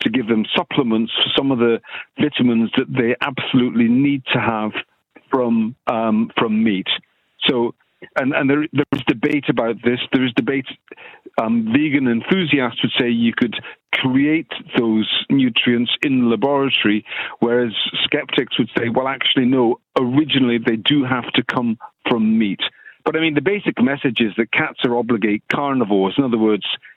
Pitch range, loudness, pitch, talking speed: 115-145 Hz, -18 LUFS, 125 Hz, 165 wpm